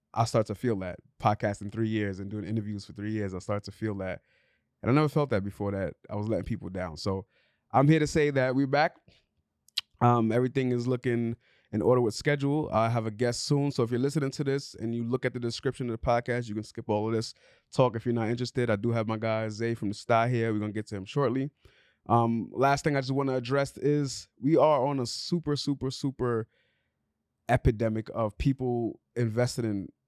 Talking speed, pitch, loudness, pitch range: 230 wpm, 115 Hz, -29 LUFS, 110-130 Hz